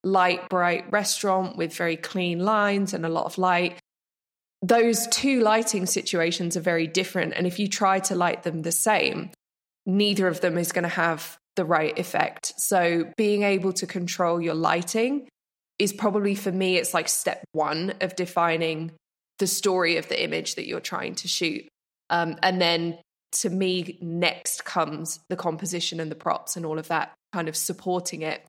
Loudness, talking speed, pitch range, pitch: -25 LUFS, 180 wpm, 170-195 Hz, 180 Hz